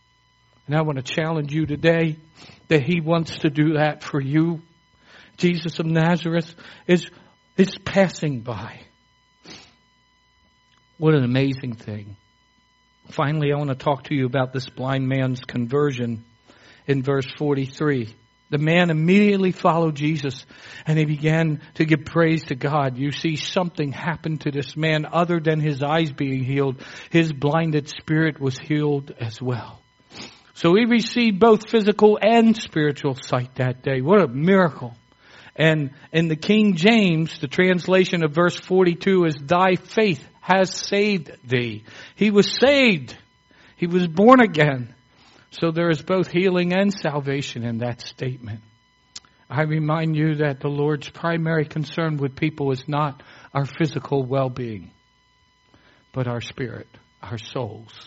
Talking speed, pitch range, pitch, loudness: 145 wpm, 130-170 Hz, 150 Hz, -21 LUFS